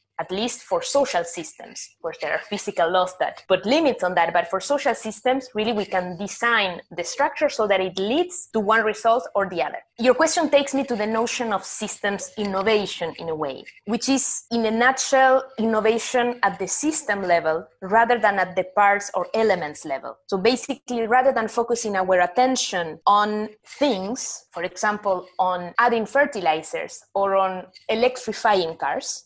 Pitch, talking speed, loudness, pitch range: 215 Hz, 170 wpm, -22 LUFS, 185-250 Hz